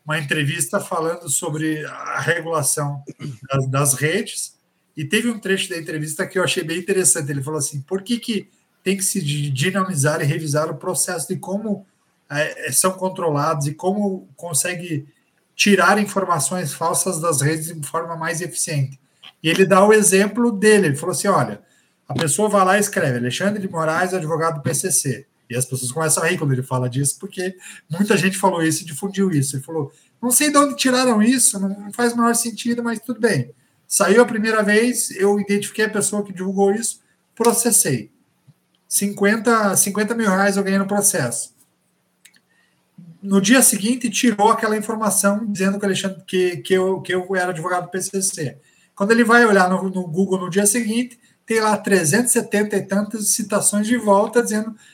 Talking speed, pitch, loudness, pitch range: 175 wpm, 190 Hz, -19 LUFS, 160-205 Hz